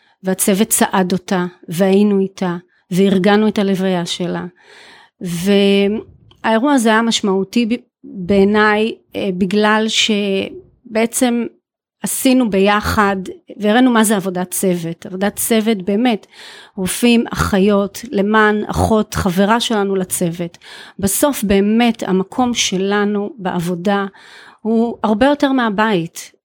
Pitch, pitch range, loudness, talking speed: 205 Hz, 190-225 Hz, -15 LUFS, 95 wpm